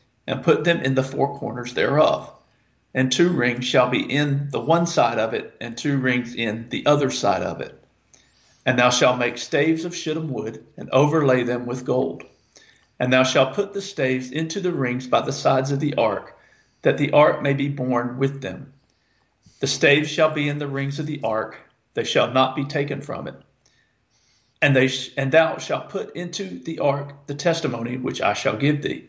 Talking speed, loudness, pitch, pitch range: 200 wpm, -21 LUFS, 140 Hz, 125-150 Hz